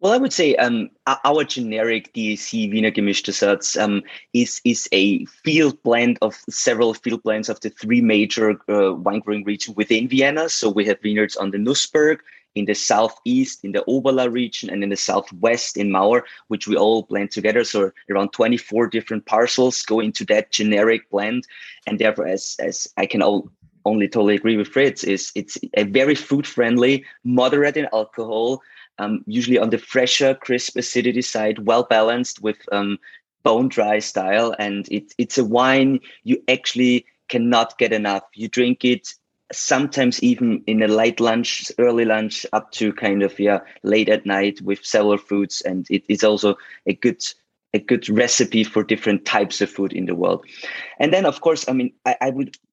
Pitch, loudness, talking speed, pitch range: 115 Hz, -19 LUFS, 180 wpm, 105-125 Hz